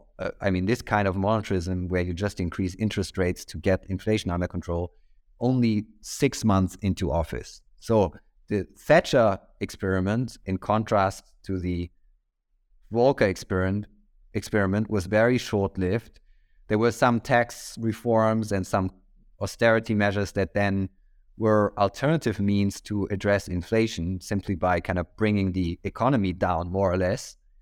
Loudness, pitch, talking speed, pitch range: -26 LUFS, 100 Hz, 140 wpm, 90-110 Hz